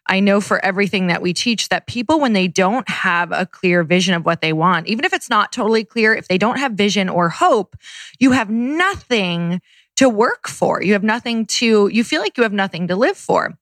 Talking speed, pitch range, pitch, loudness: 230 wpm, 185-235 Hz, 205 Hz, -17 LUFS